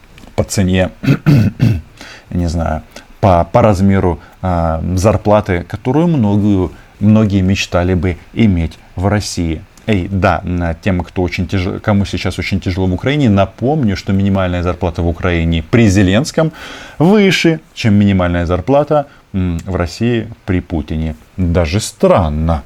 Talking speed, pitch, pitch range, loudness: 125 wpm, 95 Hz, 90-110 Hz, -14 LUFS